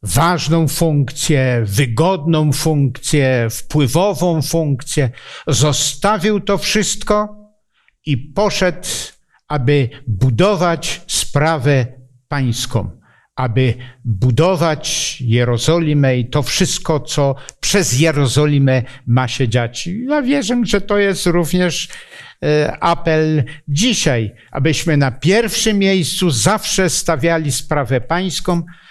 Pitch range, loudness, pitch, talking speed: 130-180 Hz, -16 LUFS, 155 Hz, 90 wpm